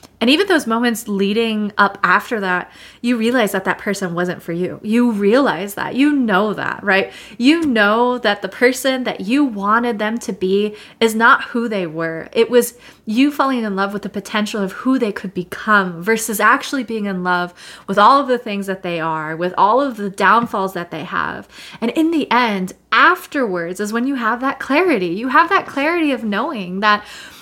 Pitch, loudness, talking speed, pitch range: 215 Hz, -17 LUFS, 200 wpm, 195-250 Hz